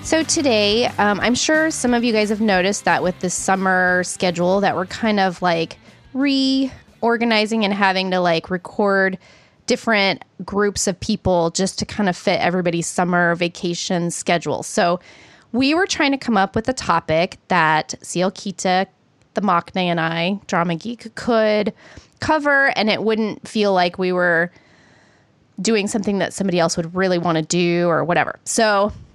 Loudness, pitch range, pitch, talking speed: -19 LUFS, 175-225 Hz, 195 Hz, 165 wpm